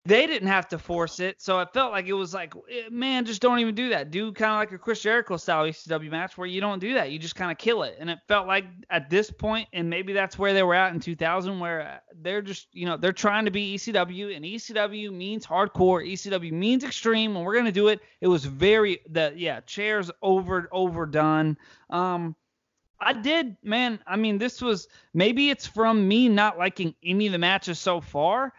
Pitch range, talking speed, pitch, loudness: 175-215 Hz, 225 wpm, 195 Hz, -25 LUFS